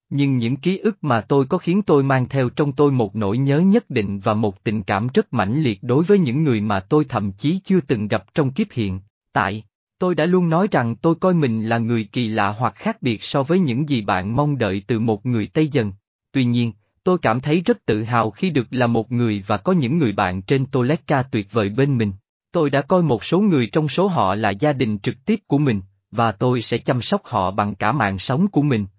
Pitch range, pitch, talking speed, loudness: 110-155 Hz, 125 Hz, 245 wpm, -20 LUFS